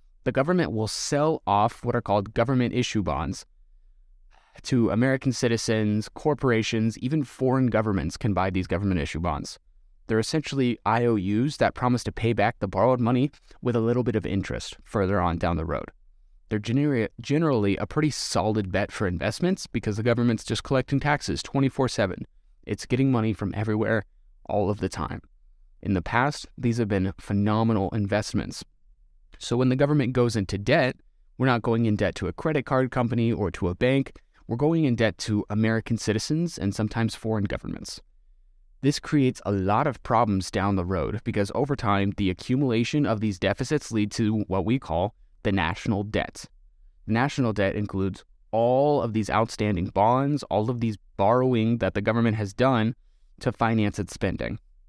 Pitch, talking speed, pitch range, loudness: 110 Hz, 175 wpm, 100-125 Hz, -25 LUFS